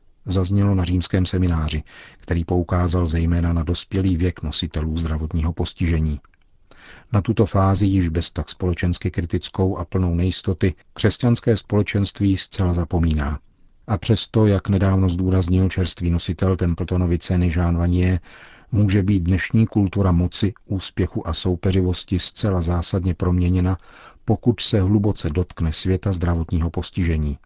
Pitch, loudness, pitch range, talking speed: 90 Hz, -21 LUFS, 85-95 Hz, 125 wpm